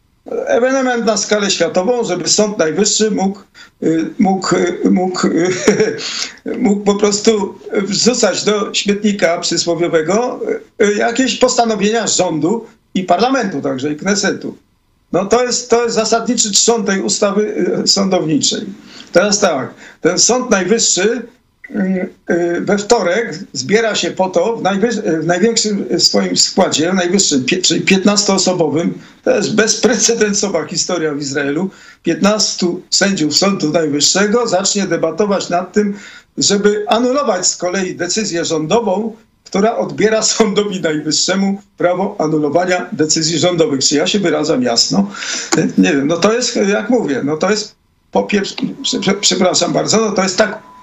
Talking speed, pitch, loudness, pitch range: 130 wpm, 200 Hz, -14 LUFS, 175-220 Hz